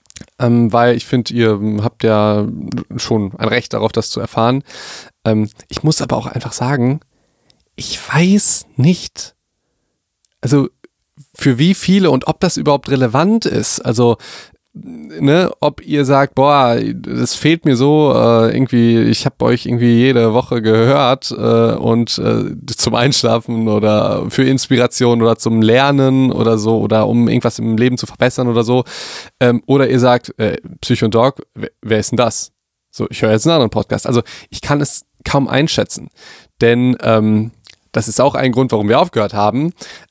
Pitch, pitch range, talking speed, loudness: 120 Hz, 115-135 Hz, 170 wpm, -14 LUFS